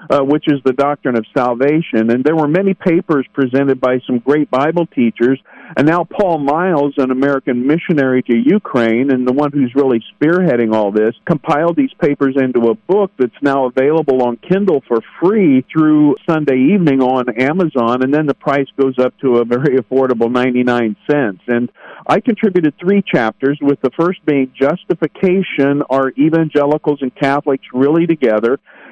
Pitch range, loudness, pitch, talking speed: 125-155 Hz, -14 LUFS, 140 Hz, 170 wpm